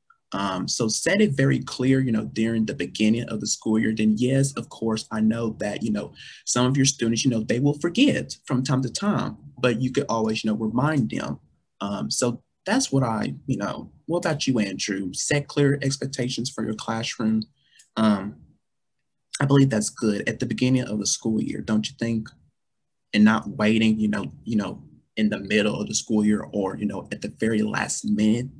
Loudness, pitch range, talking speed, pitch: -24 LUFS, 110-135 Hz, 210 wpm, 115 Hz